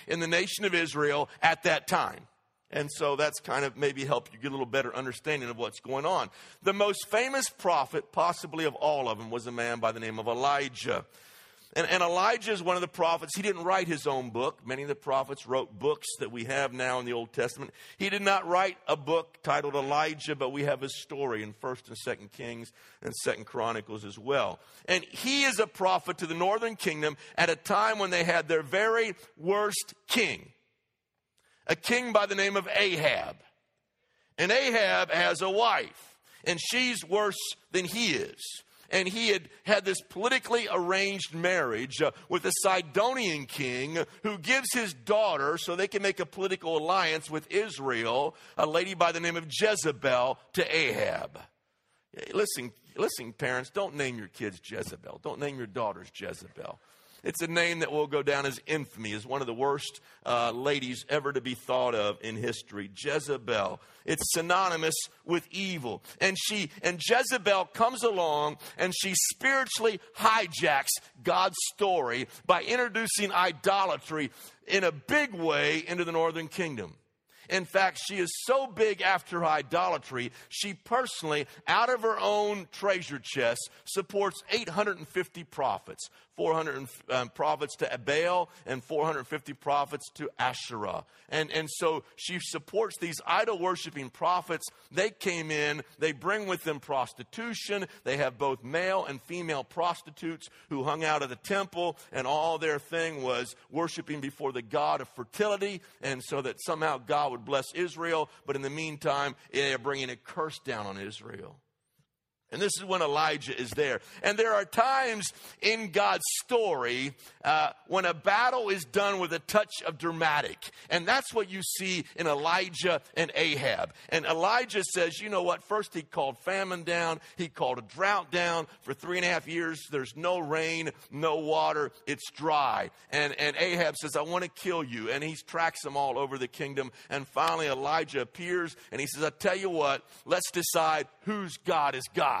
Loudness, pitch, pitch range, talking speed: -30 LUFS, 165 Hz, 140-195 Hz, 175 wpm